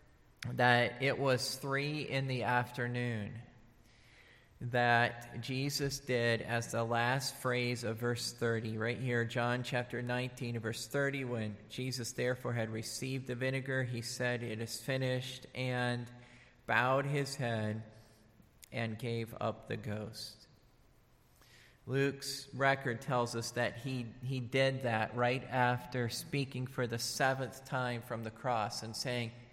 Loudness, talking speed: -35 LUFS, 135 wpm